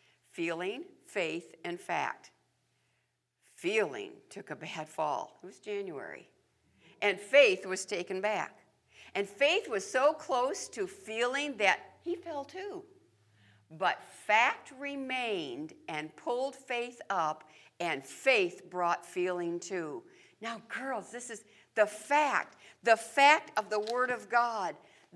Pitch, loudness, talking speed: 245 Hz, -32 LUFS, 125 wpm